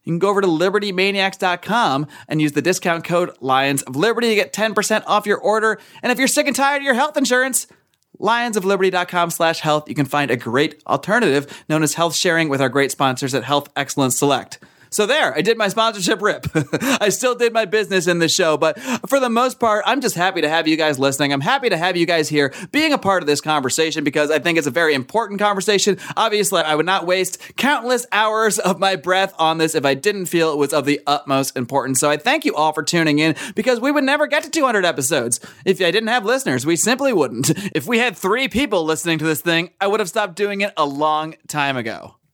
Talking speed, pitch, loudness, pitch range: 235 wpm, 180 Hz, -18 LUFS, 150-215 Hz